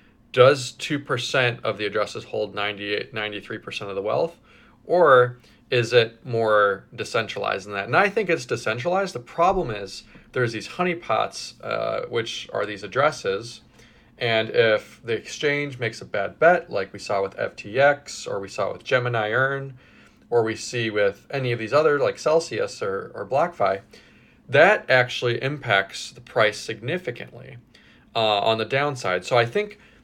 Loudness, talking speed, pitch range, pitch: -23 LUFS, 160 wpm, 110-145 Hz, 120 Hz